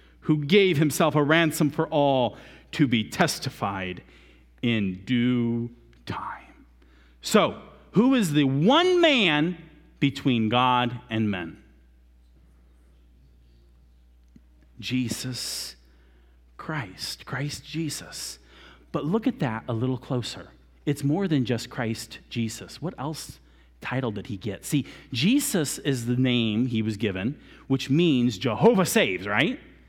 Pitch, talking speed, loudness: 120 Hz, 120 wpm, -25 LUFS